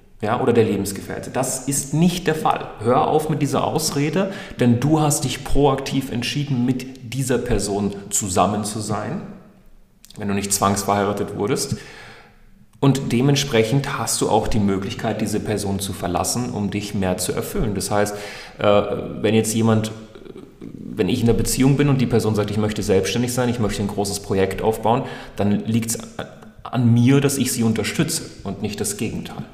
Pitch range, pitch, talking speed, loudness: 105-135 Hz, 115 Hz, 175 wpm, -20 LUFS